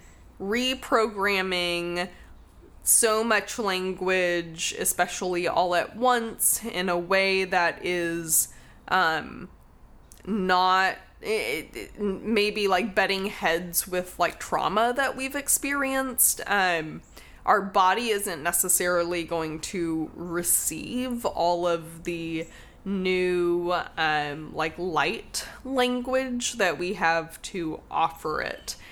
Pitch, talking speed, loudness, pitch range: 185 Hz, 100 wpm, -25 LUFS, 170-215 Hz